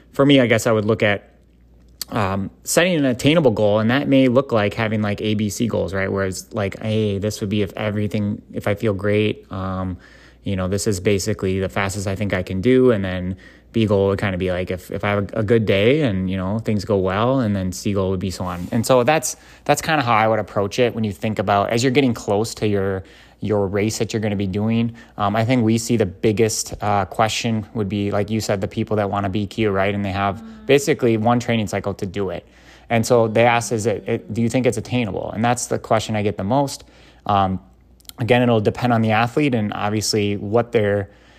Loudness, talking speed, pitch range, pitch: -20 LUFS, 245 wpm, 100-115 Hz, 105 Hz